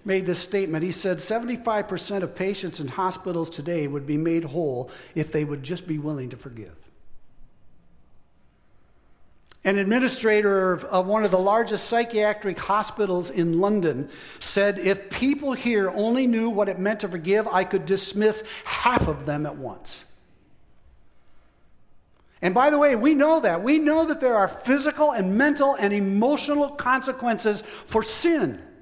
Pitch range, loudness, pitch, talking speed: 165-225 Hz, -23 LUFS, 195 Hz, 150 wpm